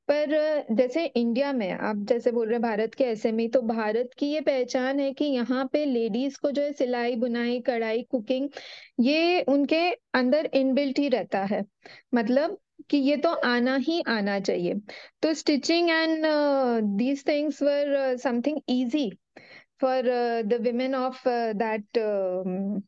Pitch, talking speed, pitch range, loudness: 260 Hz, 150 wpm, 235-290 Hz, -26 LUFS